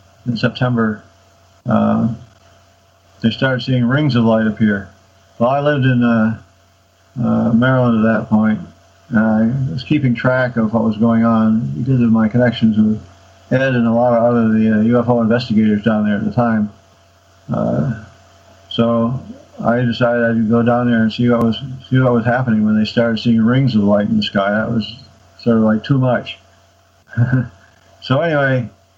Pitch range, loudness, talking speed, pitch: 100-120 Hz, -15 LUFS, 175 wpm, 115 Hz